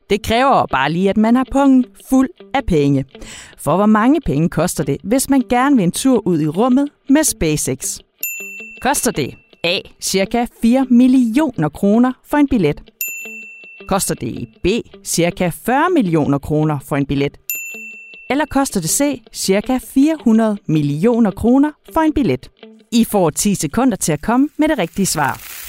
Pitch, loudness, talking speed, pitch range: 220 Hz, -16 LUFS, 165 wpm, 165-260 Hz